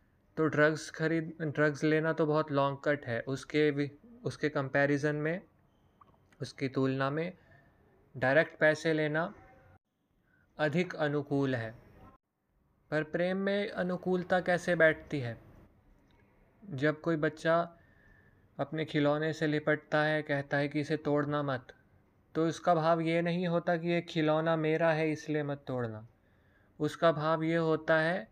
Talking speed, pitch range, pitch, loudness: 135 wpm, 140-165 Hz, 150 Hz, -31 LUFS